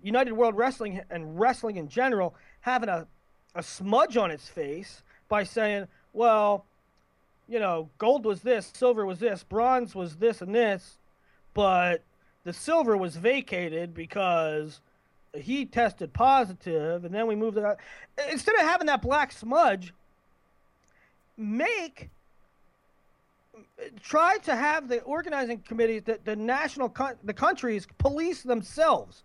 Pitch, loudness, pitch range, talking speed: 230 Hz, -27 LUFS, 195-265 Hz, 135 wpm